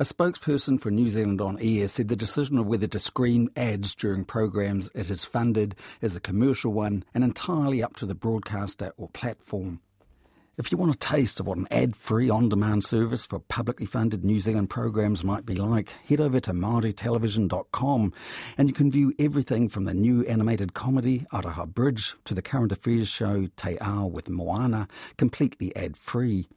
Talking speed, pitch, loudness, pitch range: 185 wpm, 110 Hz, -26 LUFS, 100-120 Hz